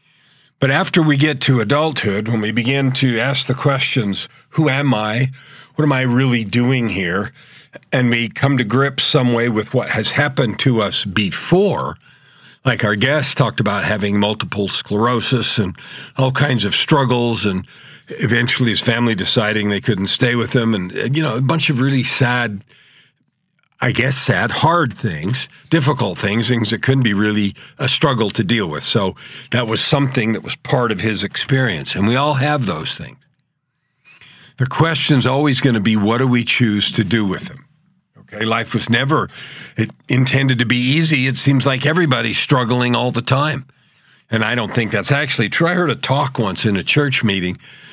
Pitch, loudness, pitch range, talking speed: 130 Hz, -16 LUFS, 115-145 Hz, 185 wpm